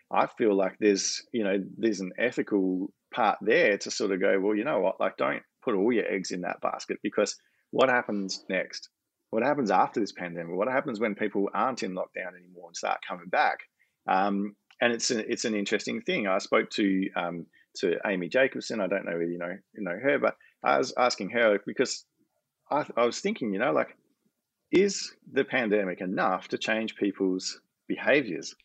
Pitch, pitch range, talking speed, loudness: 100 Hz, 95-110 Hz, 195 wpm, -28 LUFS